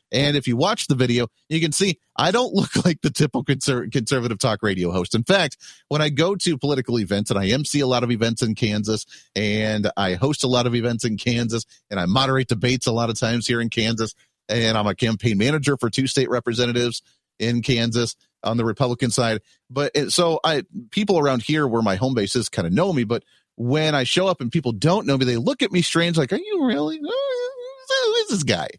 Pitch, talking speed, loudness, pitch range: 130 Hz, 225 wpm, -21 LUFS, 115-155 Hz